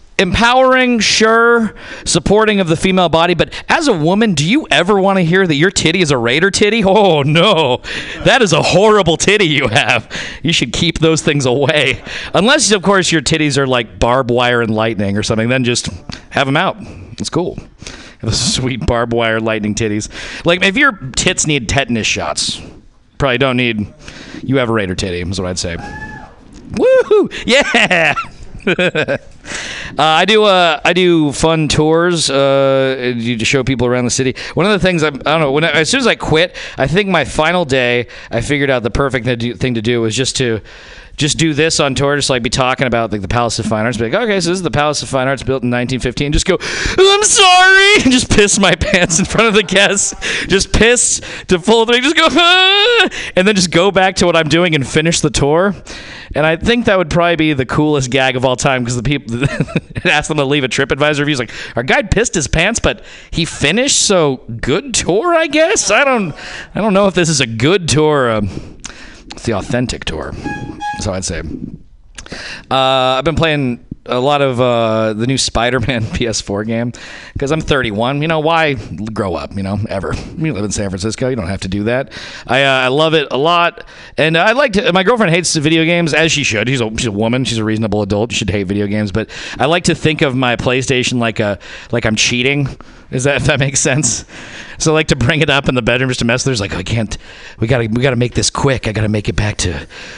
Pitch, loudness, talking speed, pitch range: 140 Hz, -13 LUFS, 230 wpm, 120-175 Hz